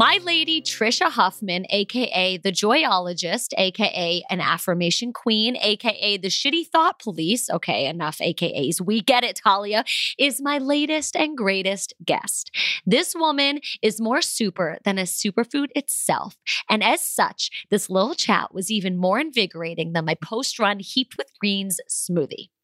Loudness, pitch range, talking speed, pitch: -22 LUFS, 185-260 Hz, 150 wpm, 210 Hz